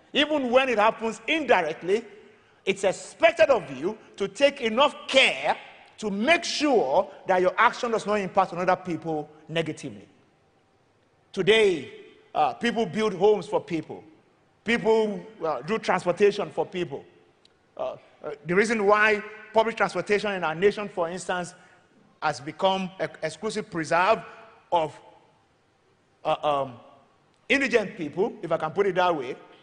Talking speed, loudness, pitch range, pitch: 135 wpm, -25 LUFS, 175-230 Hz, 205 Hz